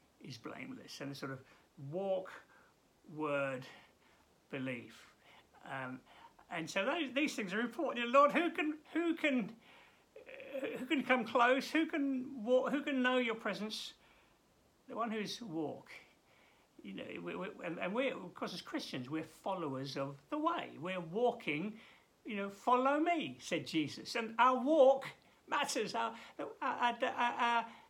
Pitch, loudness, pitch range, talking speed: 235 Hz, -36 LUFS, 170-275 Hz, 160 wpm